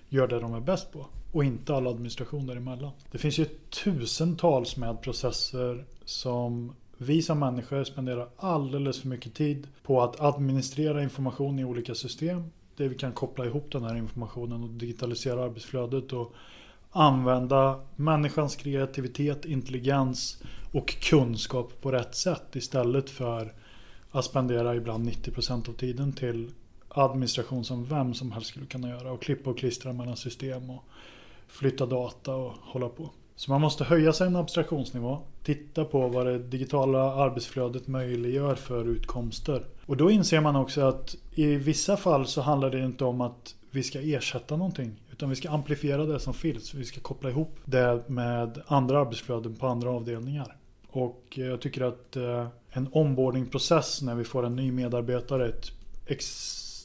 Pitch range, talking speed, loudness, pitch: 120-140 Hz, 160 wpm, -29 LUFS, 130 Hz